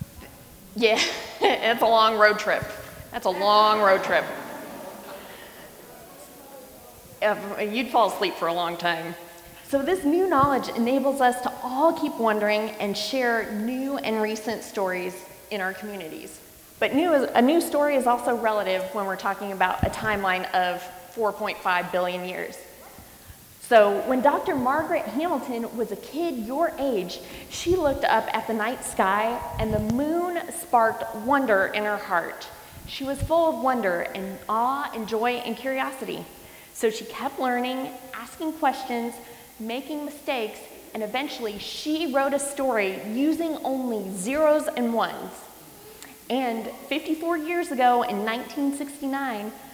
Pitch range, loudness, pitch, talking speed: 210-275 Hz, -25 LUFS, 235 Hz, 140 wpm